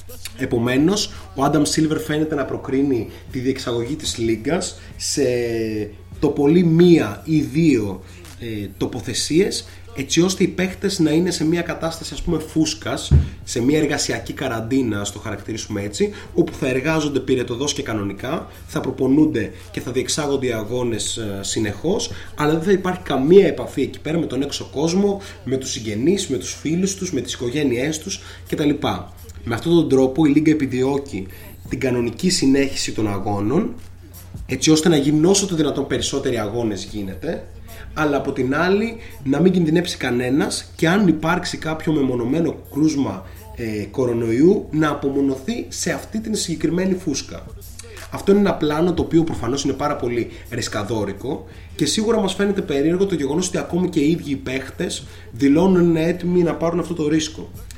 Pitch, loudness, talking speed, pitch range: 135 Hz, -20 LUFS, 160 wpm, 105-160 Hz